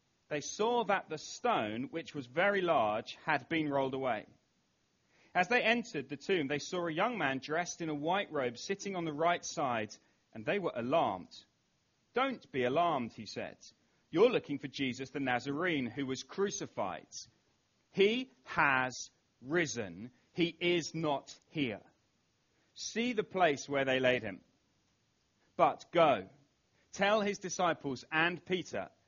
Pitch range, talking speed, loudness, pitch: 140-195 Hz, 150 wpm, -34 LUFS, 160 Hz